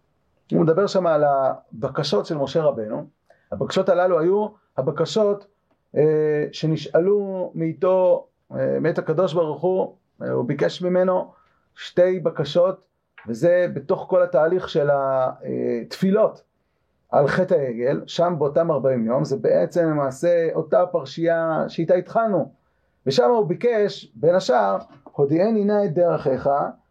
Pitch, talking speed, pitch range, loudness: 175 Hz, 125 wpm, 150-190 Hz, -21 LUFS